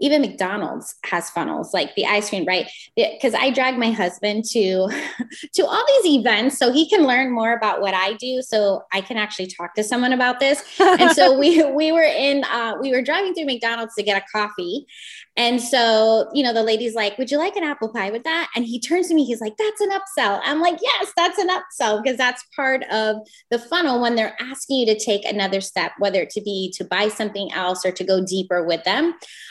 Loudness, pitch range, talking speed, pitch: -20 LUFS, 210-300 Hz, 230 wpm, 240 Hz